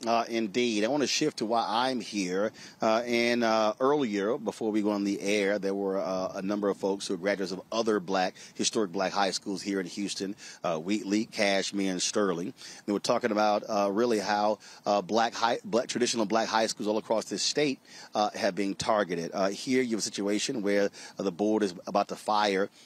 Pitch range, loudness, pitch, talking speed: 100-110 Hz, -29 LUFS, 105 Hz, 215 wpm